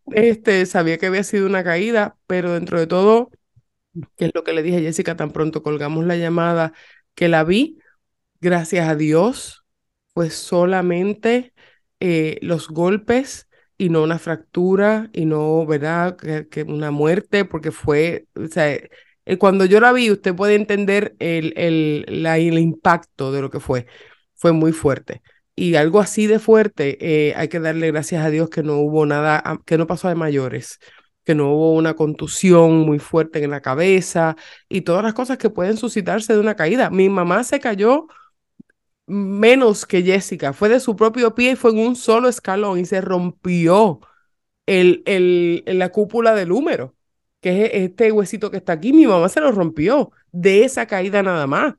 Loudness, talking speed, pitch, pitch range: -17 LUFS, 175 wpm, 180 Hz, 160-210 Hz